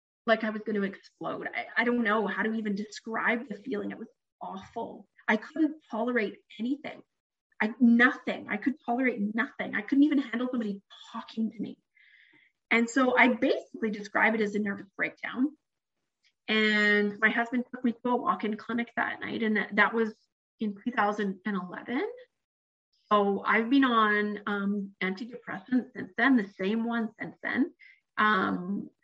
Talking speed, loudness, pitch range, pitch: 160 wpm, -28 LUFS, 210-250 Hz, 225 Hz